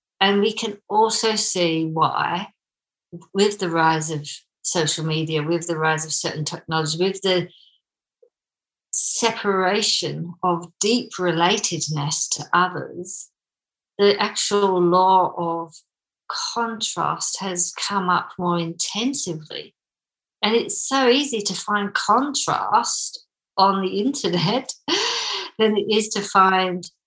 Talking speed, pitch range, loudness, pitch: 115 wpm, 170-215 Hz, -21 LUFS, 185 Hz